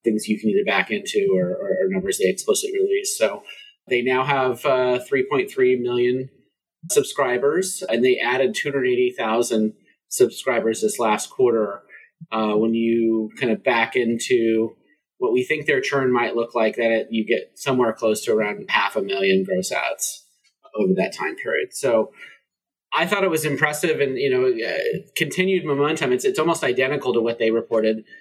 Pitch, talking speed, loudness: 140 Hz, 170 wpm, -21 LUFS